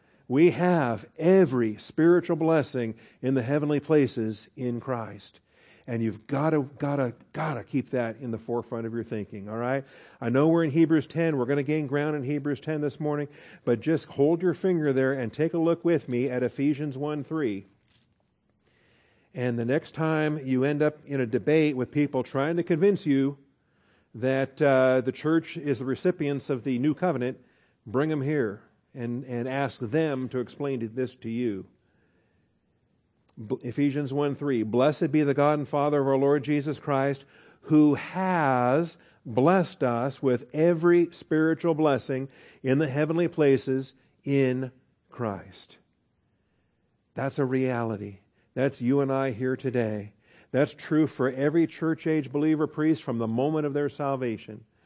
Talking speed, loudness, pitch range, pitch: 165 wpm, -26 LUFS, 125-150 Hz, 140 Hz